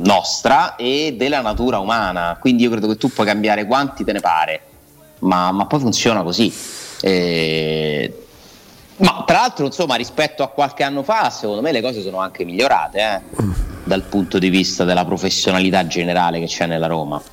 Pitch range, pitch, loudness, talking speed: 85-120 Hz, 95 Hz, -17 LUFS, 175 wpm